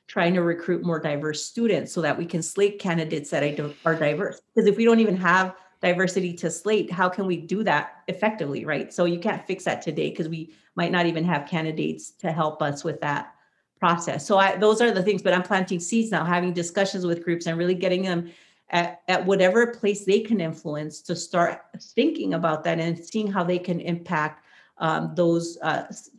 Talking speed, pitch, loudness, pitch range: 205 wpm, 175 Hz, -24 LUFS, 165-195 Hz